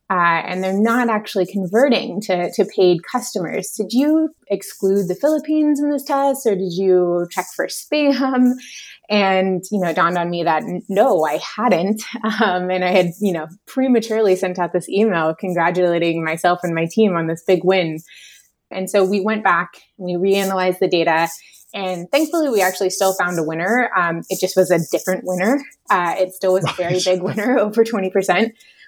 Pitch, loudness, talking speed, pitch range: 190 Hz, -18 LUFS, 190 wpm, 180-220 Hz